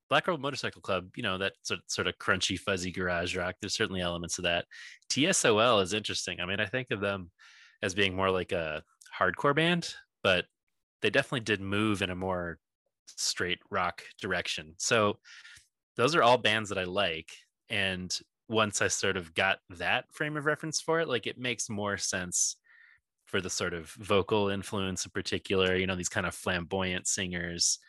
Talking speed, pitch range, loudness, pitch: 185 wpm, 90-110 Hz, -30 LUFS, 95 Hz